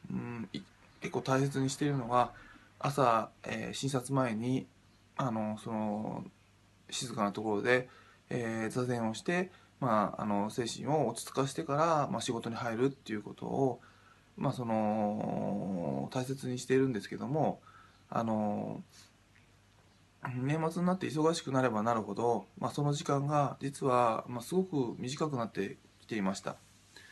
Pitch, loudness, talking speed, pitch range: 120 Hz, -34 LUFS, 280 characters per minute, 105-135 Hz